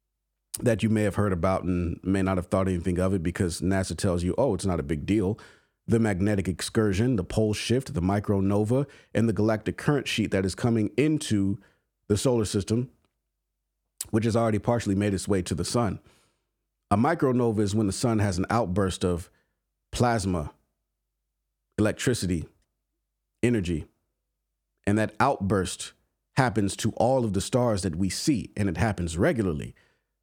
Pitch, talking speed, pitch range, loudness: 100 Hz, 165 wpm, 90-110 Hz, -26 LUFS